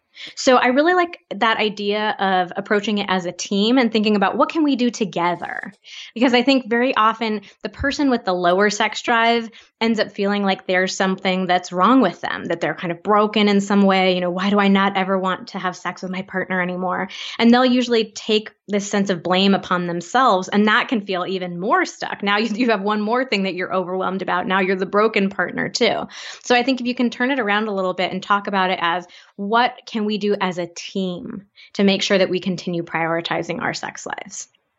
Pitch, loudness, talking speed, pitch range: 205 Hz, -19 LUFS, 230 wpm, 185-230 Hz